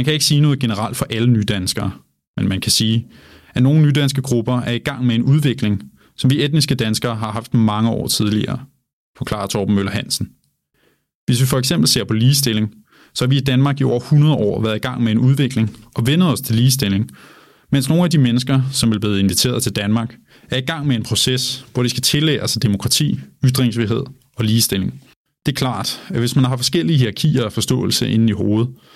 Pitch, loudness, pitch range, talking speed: 125 Hz, -17 LUFS, 110-135 Hz, 215 wpm